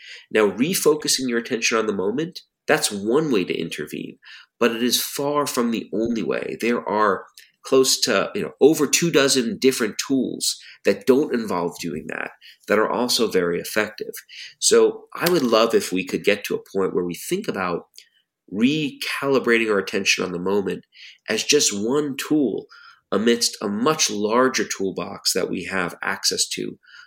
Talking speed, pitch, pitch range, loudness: 170 wpm, 135 Hz, 115-195 Hz, -21 LUFS